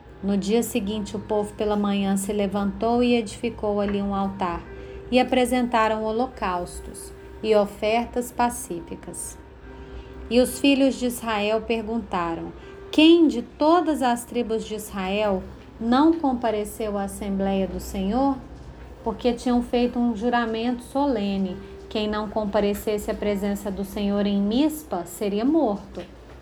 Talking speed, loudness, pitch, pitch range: 125 wpm, -24 LUFS, 220 Hz, 200-245 Hz